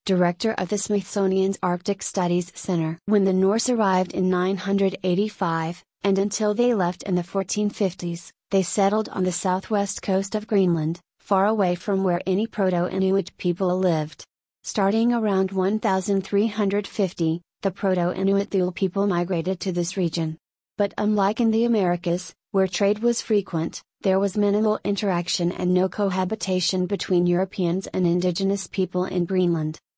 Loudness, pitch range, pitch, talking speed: -23 LUFS, 180-200 Hz, 190 Hz, 145 wpm